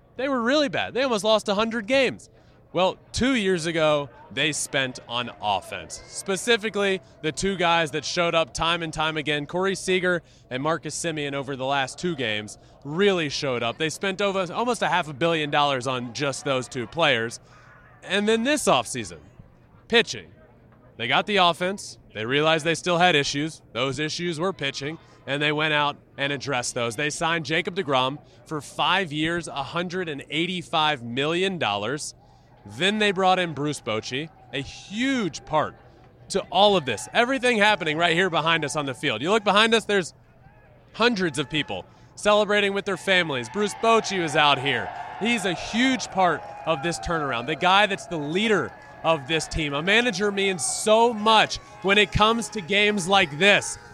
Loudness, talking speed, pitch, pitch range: -23 LUFS, 175 wpm, 165 Hz, 140-195 Hz